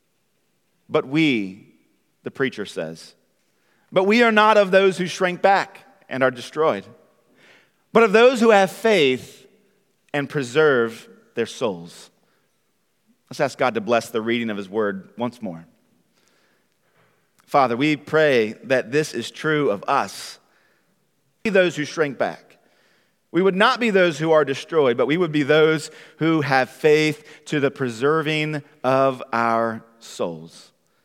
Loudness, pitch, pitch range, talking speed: -20 LUFS, 150 Hz, 130-190 Hz, 150 wpm